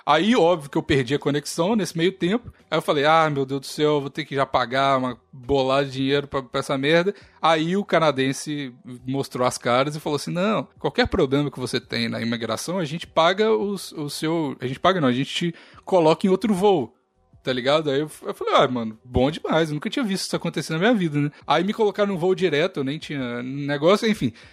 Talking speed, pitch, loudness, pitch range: 230 wpm, 150 Hz, -22 LUFS, 135-170 Hz